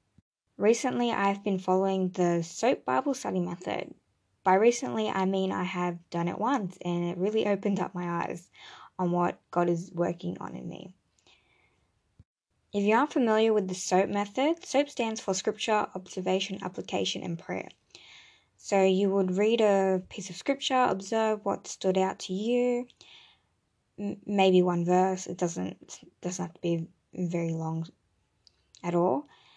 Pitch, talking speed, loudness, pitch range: 190 Hz, 155 wpm, -29 LUFS, 175-215 Hz